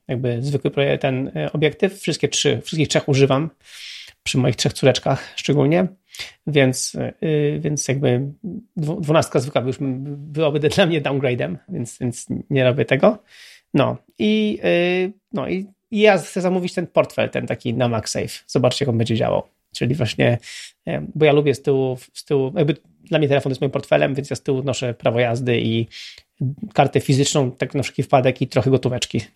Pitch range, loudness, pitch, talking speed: 130-165 Hz, -20 LUFS, 145 Hz, 160 wpm